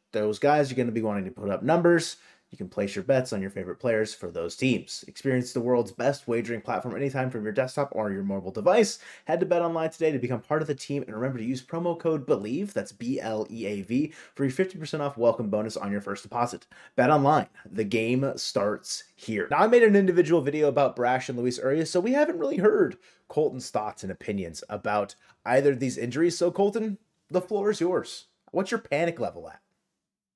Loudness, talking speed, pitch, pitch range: -27 LUFS, 225 wpm, 140 Hz, 120-170 Hz